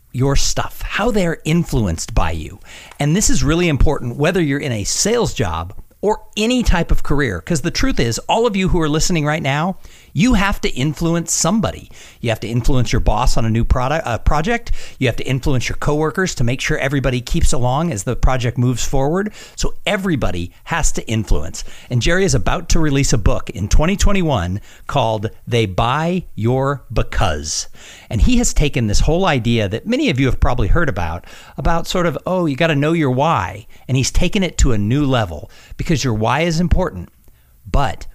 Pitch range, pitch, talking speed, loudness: 115-170 Hz, 135 Hz, 200 wpm, -18 LUFS